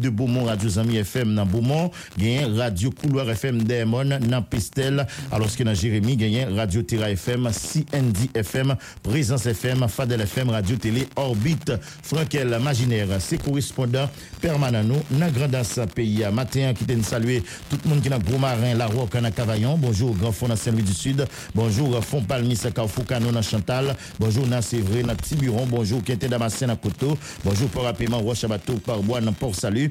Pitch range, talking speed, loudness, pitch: 110-135 Hz, 175 wpm, -23 LUFS, 120 Hz